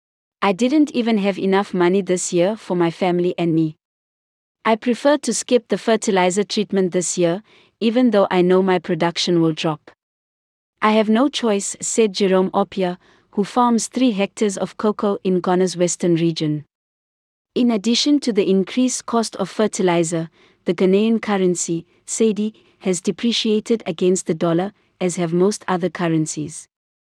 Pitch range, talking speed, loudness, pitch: 175-220 Hz, 155 wpm, -19 LUFS, 190 Hz